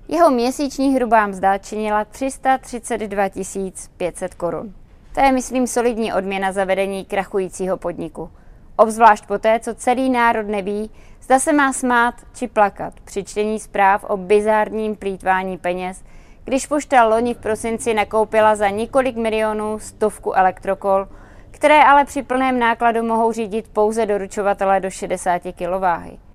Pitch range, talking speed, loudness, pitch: 195-240 Hz, 135 wpm, -18 LUFS, 215 Hz